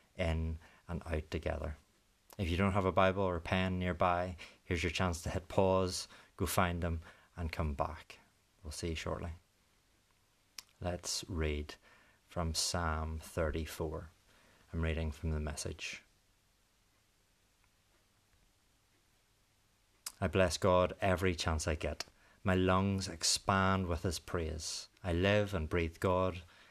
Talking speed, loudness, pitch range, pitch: 130 wpm, -35 LUFS, 80-100 Hz, 90 Hz